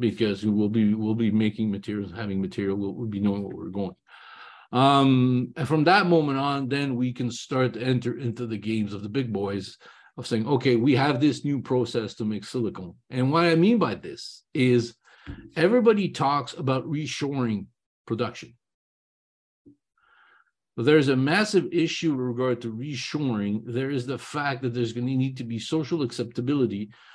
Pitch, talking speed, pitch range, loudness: 125 Hz, 180 wpm, 110-140 Hz, -25 LUFS